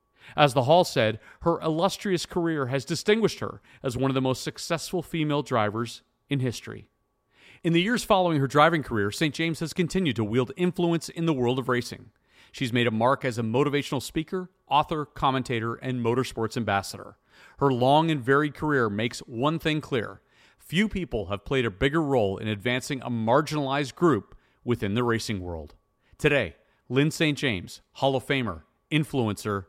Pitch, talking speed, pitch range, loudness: 135 Hz, 170 wpm, 115-160 Hz, -26 LUFS